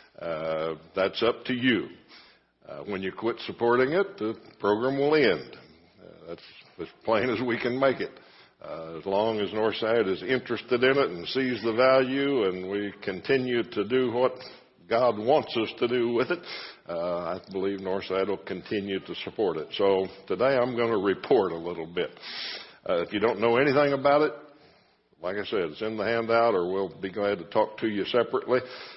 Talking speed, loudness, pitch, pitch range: 190 wpm, -27 LUFS, 115 Hz, 100-130 Hz